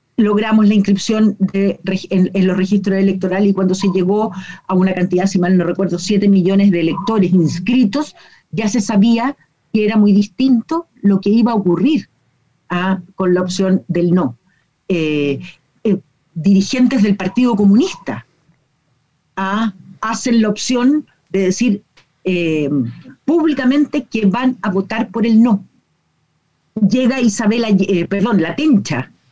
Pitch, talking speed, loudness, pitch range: 195 Hz, 145 wpm, -15 LUFS, 180-220 Hz